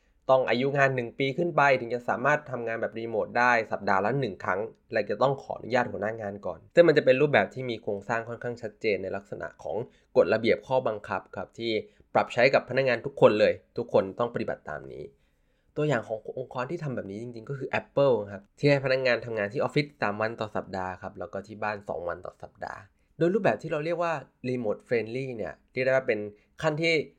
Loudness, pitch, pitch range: -27 LUFS, 125 Hz, 110-145 Hz